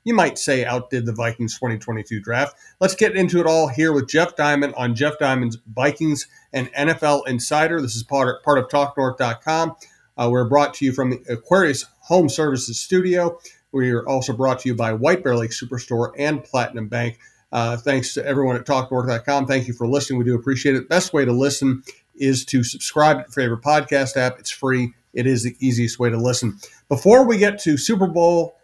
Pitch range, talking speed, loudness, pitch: 125-150 Hz, 205 wpm, -20 LUFS, 135 Hz